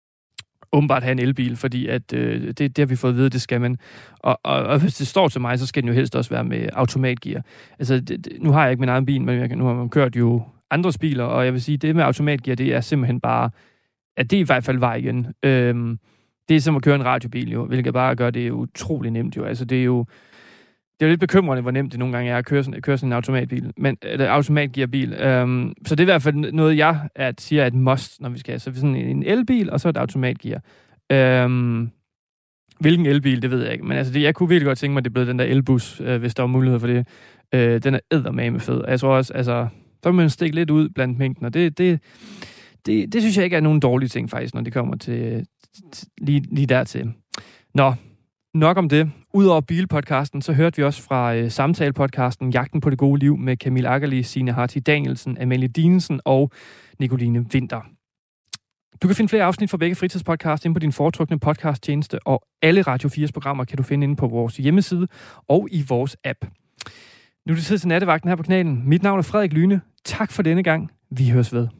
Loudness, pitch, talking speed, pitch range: -20 LUFS, 135 Hz, 240 wpm, 125-155 Hz